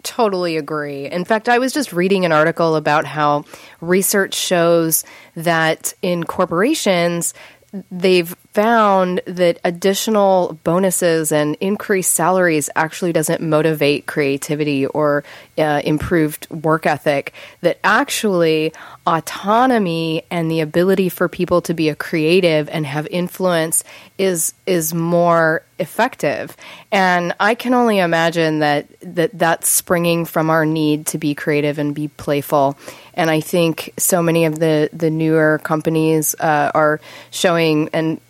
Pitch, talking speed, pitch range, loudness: 165 Hz, 135 wpm, 155-185 Hz, -17 LUFS